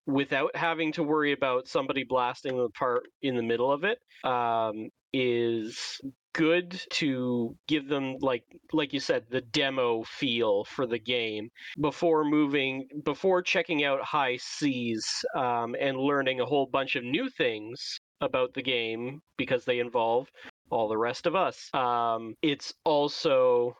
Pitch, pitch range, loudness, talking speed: 135 Hz, 125-155 Hz, -29 LUFS, 150 wpm